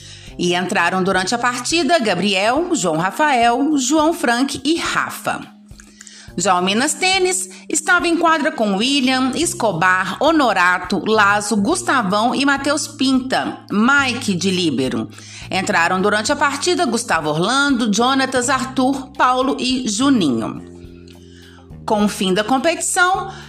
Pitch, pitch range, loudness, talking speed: 245 Hz, 185-285 Hz, -17 LUFS, 120 wpm